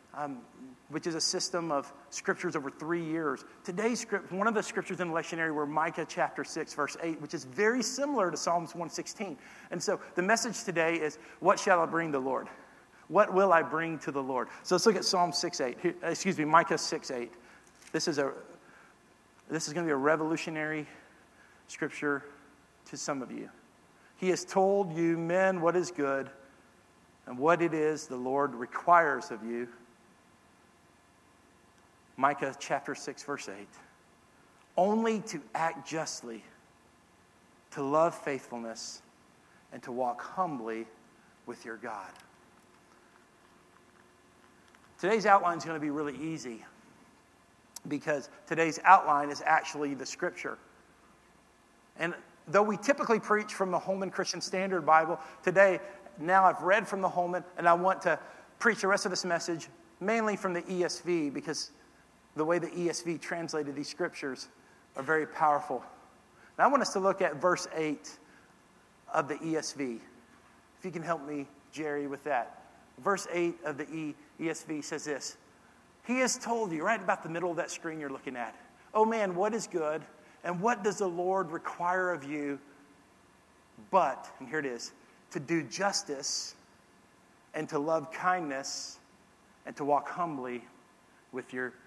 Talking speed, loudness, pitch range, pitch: 160 wpm, -31 LUFS, 145-185 Hz, 165 Hz